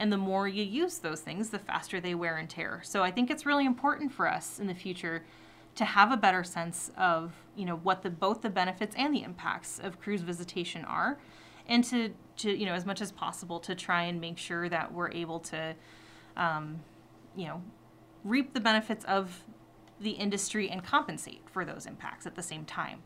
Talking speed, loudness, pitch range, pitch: 210 wpm, -32 LUFS, 170-215 Hz, 185 Hz